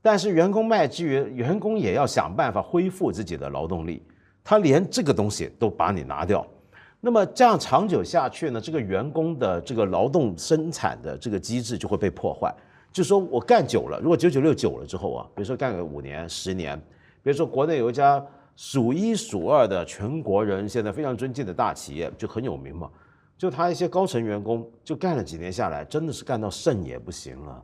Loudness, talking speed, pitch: -24 LUFS, 315 characters per minute, 130 Hz